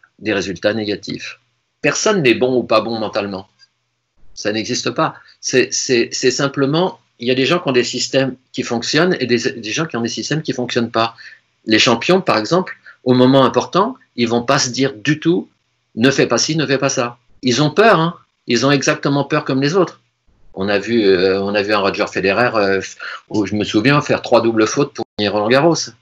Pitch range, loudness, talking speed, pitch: 110-145 Hz, -16 LUFS, 220 wpm, 125 Hz